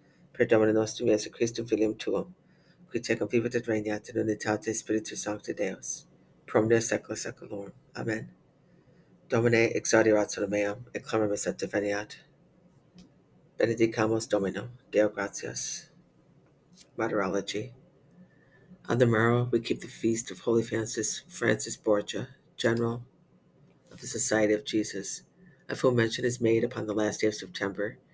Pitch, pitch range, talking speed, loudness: 115 Hz, 105-120 Hz, 135 wpm, -29 LUFS